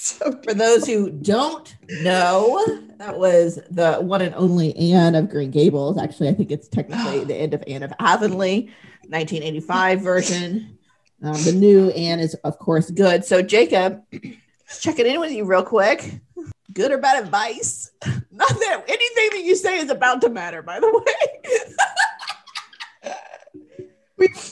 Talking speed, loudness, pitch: 155 wpm, -19 LUFS, 195 Hz